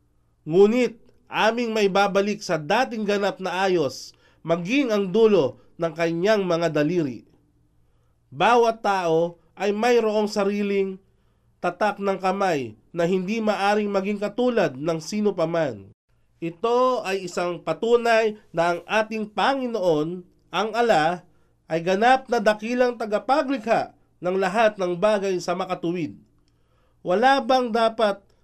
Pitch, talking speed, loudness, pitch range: 200 Hz, 120 wpm, -23 LUFS, 170-220 Hz